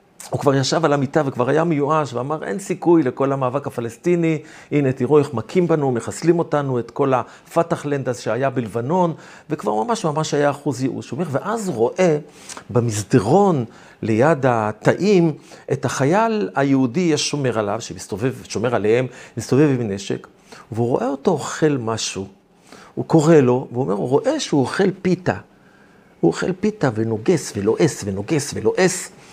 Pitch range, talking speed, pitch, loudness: 125-165 Hz, 150 wpm, 140 Hz, -20 LUFS